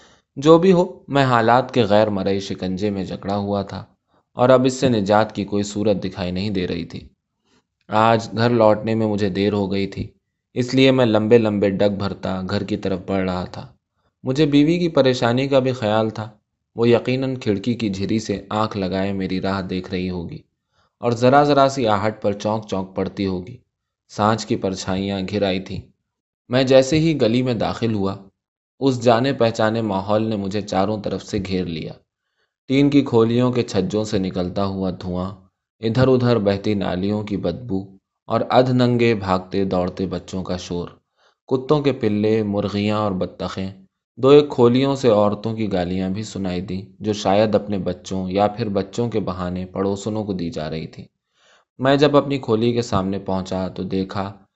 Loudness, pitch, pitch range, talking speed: -20 LUFS, 105 Hz, 95-120 Hz, 185 wpm